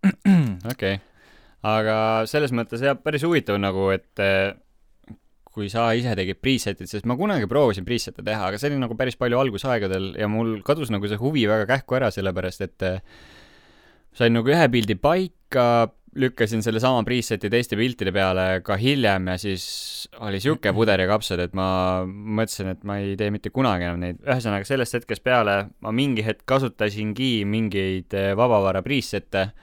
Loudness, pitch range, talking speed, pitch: -23 LUFS, 95-125 Hz, 165 wpm, 110 Hz